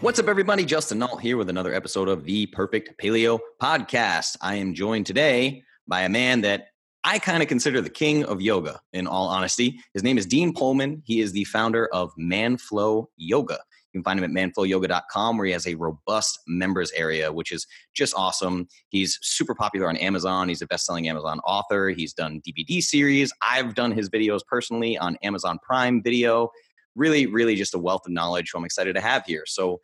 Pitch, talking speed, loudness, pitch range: 100 Hz, 200 wpm, -24 LUFS, 90-120 Hz